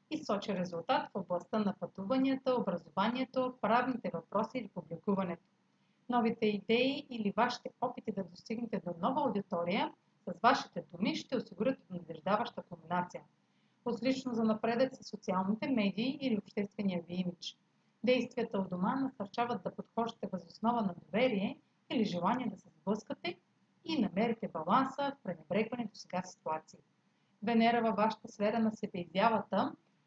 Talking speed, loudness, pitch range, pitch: 135 wpm, -35 LUFS, 190-245 Hz, 215 Hz